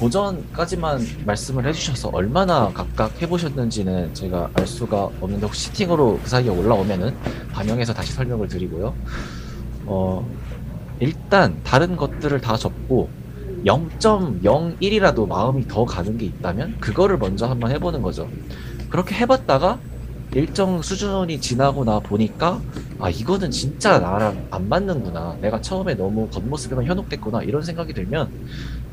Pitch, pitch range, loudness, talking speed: 125 Hz, 105-160 Hz, -21 LUFS, 310 characters per minute